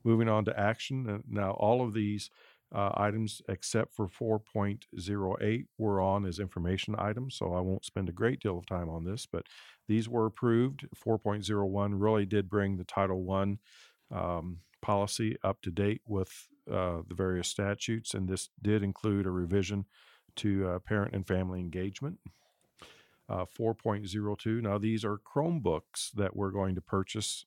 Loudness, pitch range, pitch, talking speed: -33 LUFS, 95-110 Hz, 100 Hz, 160 wpm